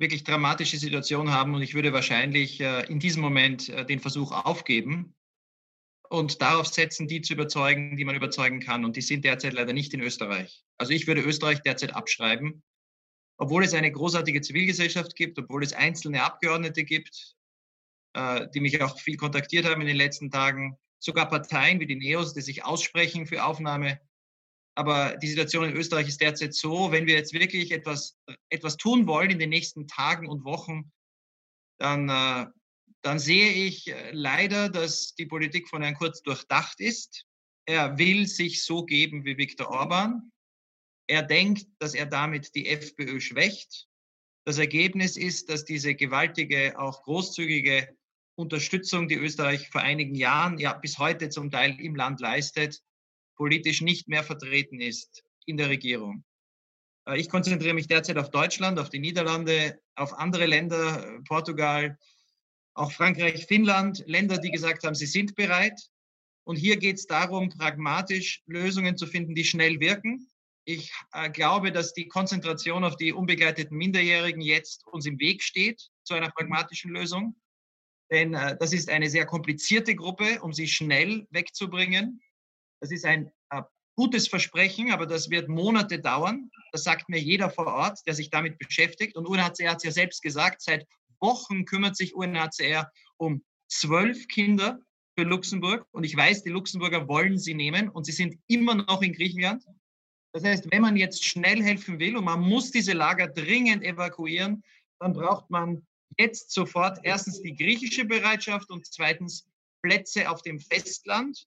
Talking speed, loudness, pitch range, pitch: 160 wpm, -26 LUFS, 150-185 Hz, 165 Hz